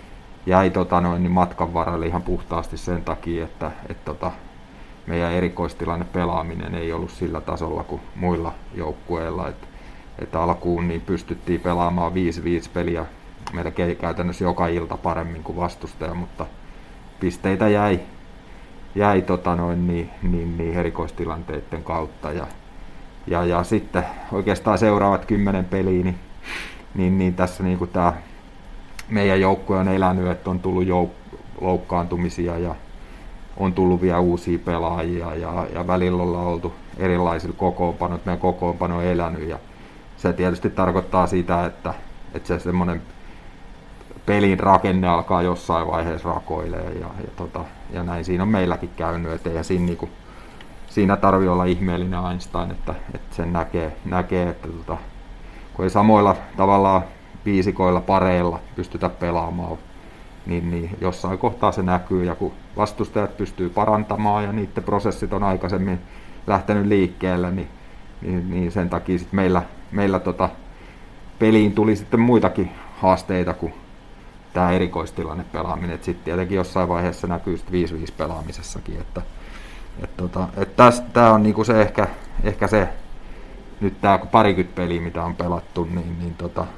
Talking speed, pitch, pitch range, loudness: 140 wpm, 90 Hz, 85-95 Hz, -22 LUFS